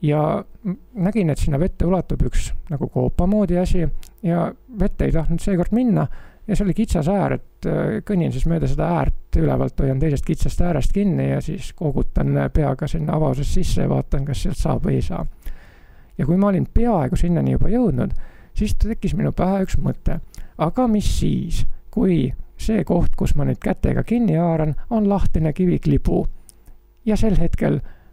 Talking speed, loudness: 175 wpm, -21 LUFS